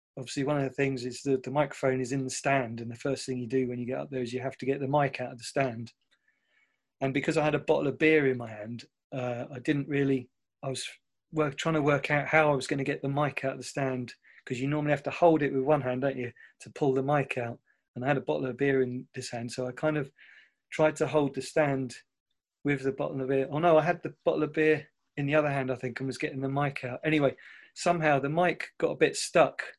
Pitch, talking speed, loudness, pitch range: 135 Hz, 280 wpm, -29 LUFS, 130-150 Hz